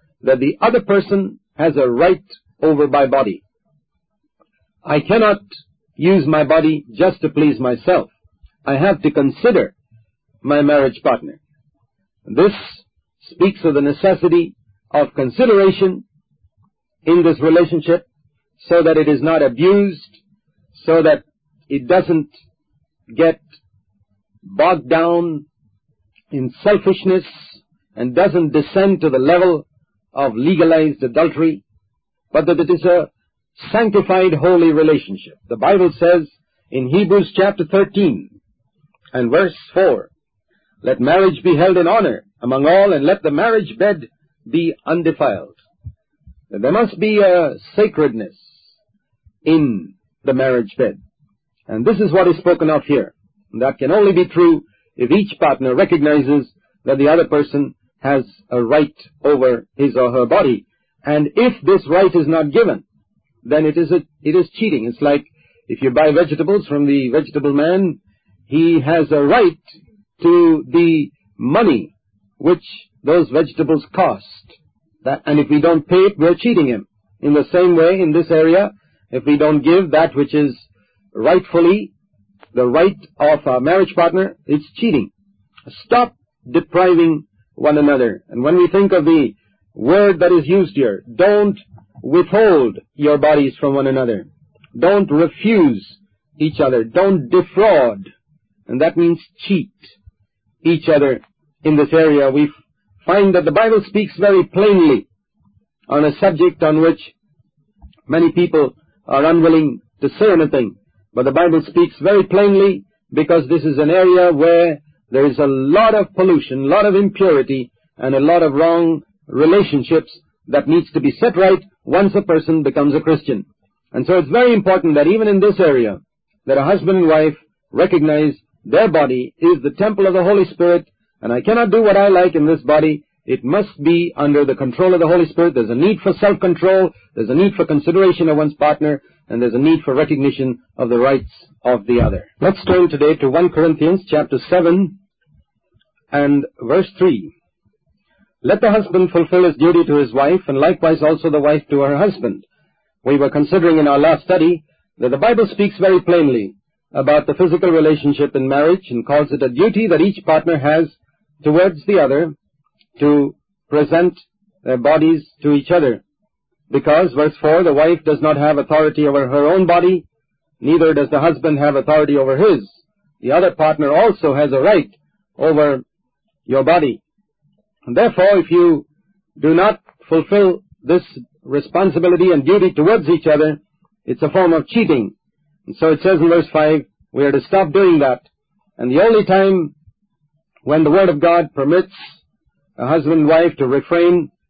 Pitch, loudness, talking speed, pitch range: 160 Hz, -14 LUFS, 160 wpm, 145-185 Hz